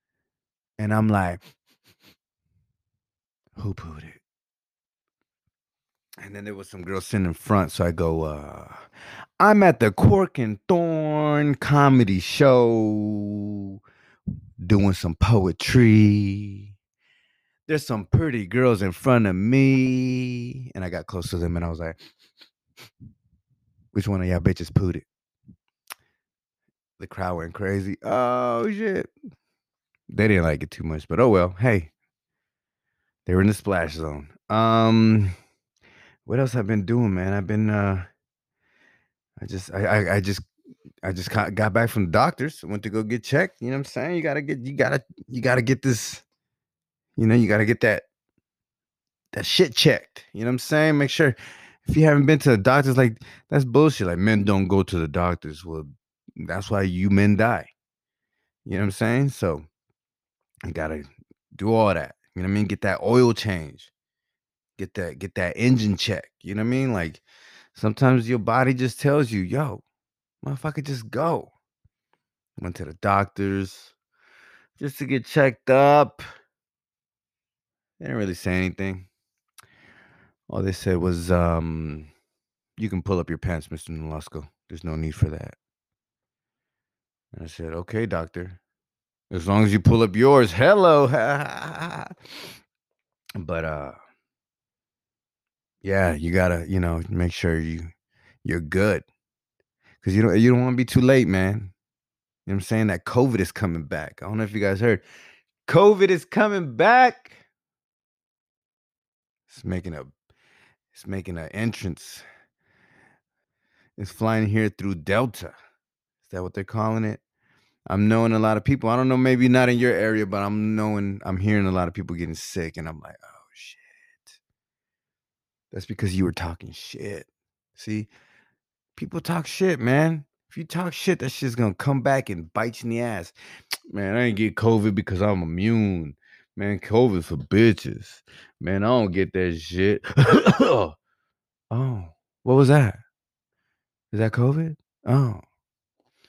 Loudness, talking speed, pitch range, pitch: -22 LUFS, 160 wpm, 95-125 Hz, 105 Hz